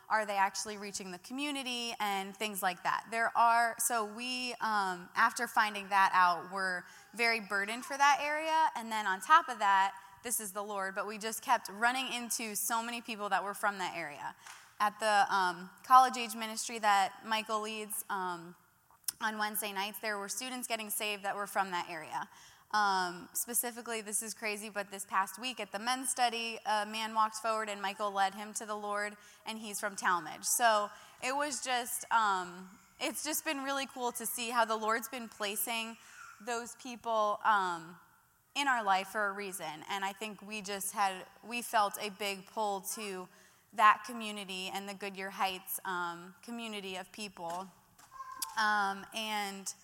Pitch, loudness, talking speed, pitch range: 215 Hz, -33 LUFS, 180 wpm, 195-235 Hz